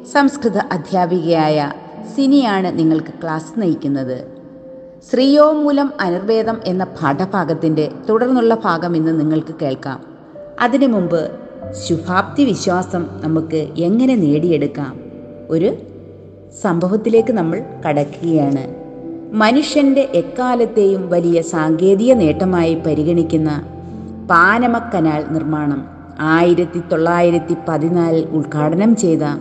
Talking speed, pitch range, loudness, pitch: 80 wpm, 155-225 Hz, -16 LUFS, 170 Hz